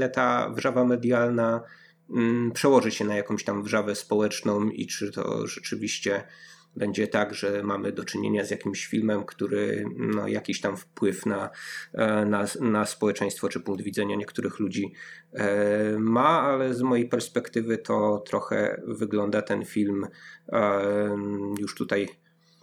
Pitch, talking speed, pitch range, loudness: 105 Hz, 130 wpm, 100-115 Hz, -27 LUFS